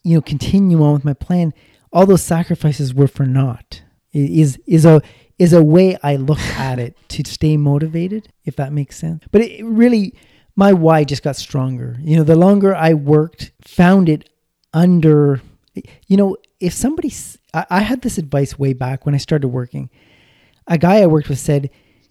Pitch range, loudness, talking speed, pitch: 140-180 Hz, -15 LUFS, 180 wpm, 155 Hz